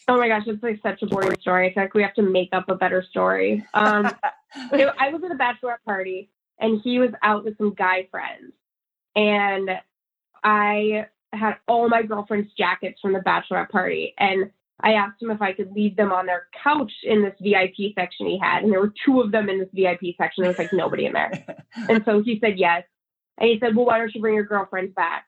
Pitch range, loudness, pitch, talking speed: 190-225 Hz, -22 LUFS, 210 Hz, 225 wpm